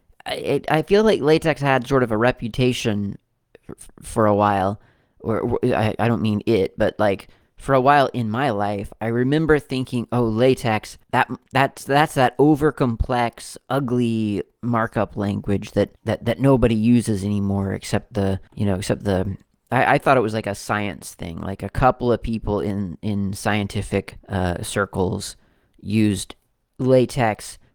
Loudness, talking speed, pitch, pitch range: -21 LUFS, 155 wpm, 110 Hz, 100-125 Hz